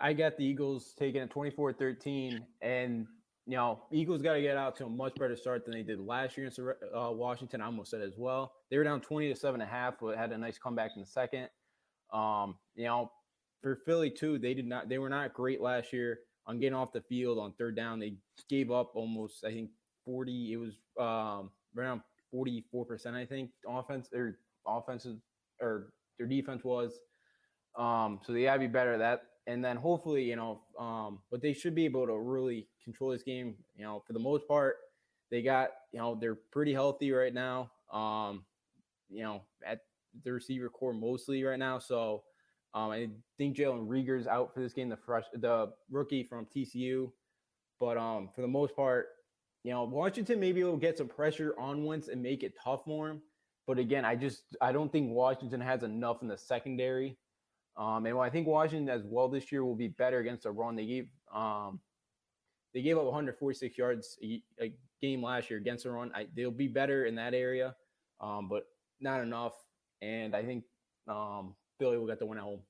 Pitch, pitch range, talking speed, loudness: 125 Hz, 115-135 Hz, 205 wpm, -36 LUFS